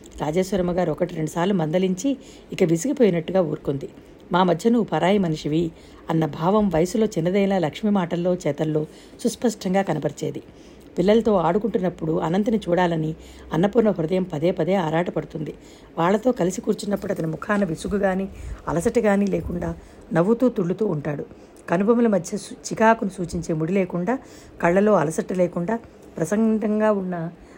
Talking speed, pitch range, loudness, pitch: 115 wpm, 165-210 Hz, -22 LUFS, 185 Hz